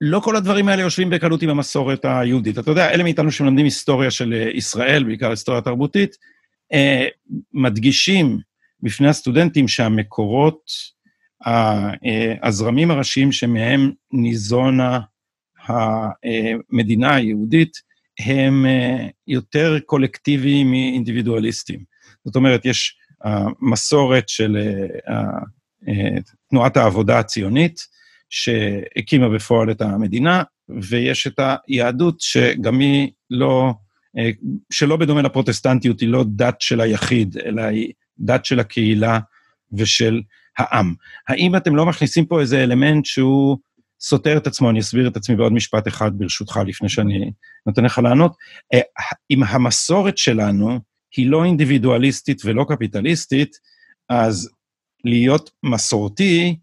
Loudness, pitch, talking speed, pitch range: -17 LUFS, 125 Hz, 110 wpm, 115-145 Hz